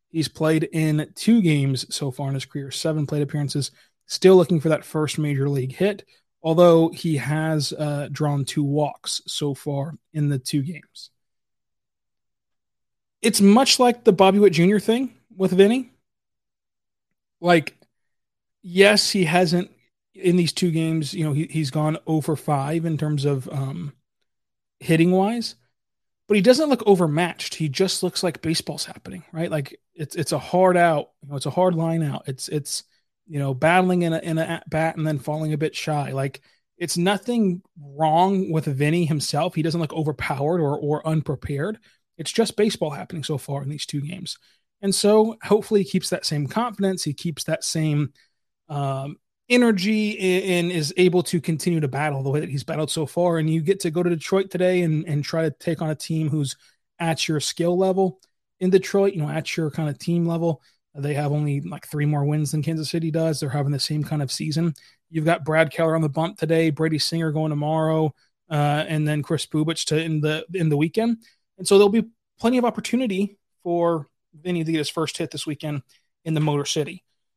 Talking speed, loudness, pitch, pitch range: 195 wpm, -22 LUFS, 160 Hz, 150-180 Hz